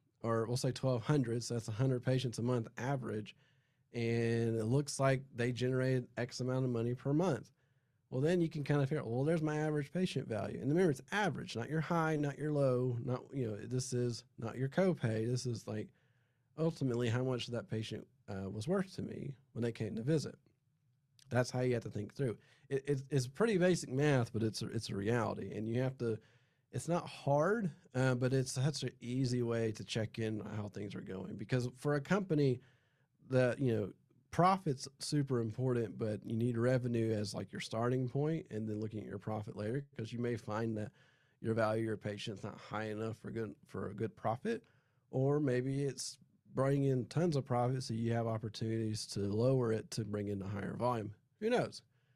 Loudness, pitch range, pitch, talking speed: -37 LUFS, 115-140 Hz, 125 Hz, 205 wpm